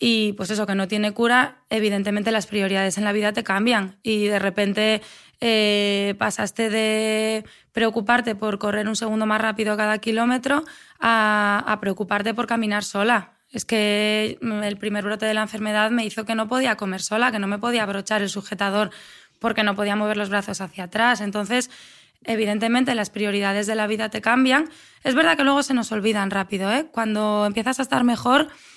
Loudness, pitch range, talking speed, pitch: -22 LUFS, 205-230 Hz, 185 wpm, 215 Hz